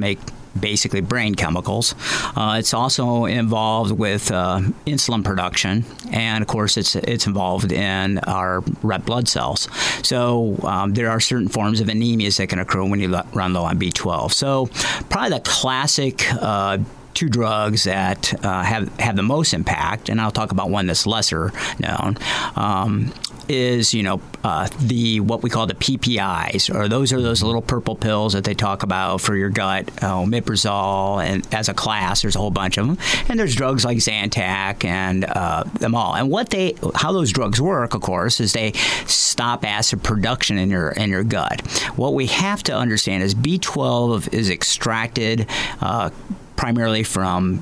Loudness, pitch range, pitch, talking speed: -19 LUFS, 95-120 Hz, 110 Hz, 175 wpm